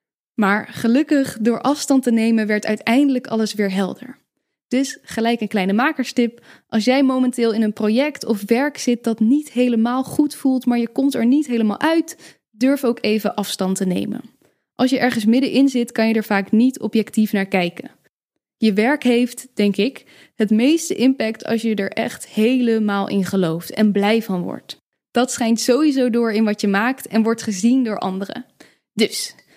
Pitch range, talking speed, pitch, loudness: 215-255 Hz, 180 wpm, 230 Hz, -19 LUFS